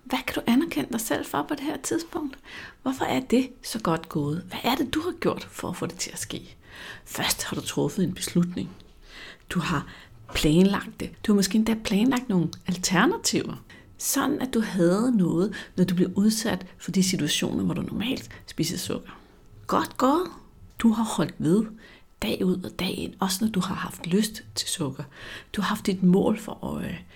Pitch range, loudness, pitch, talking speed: 180-250 Hz, -26 LUFS, 210 Hz, 200 wpm